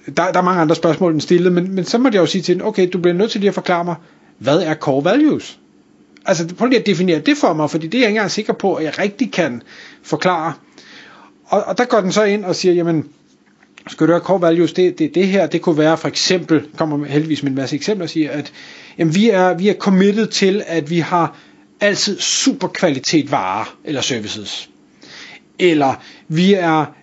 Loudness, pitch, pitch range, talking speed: -16 LUFS, 180 Hz, 160-200 Hz, 230 wpm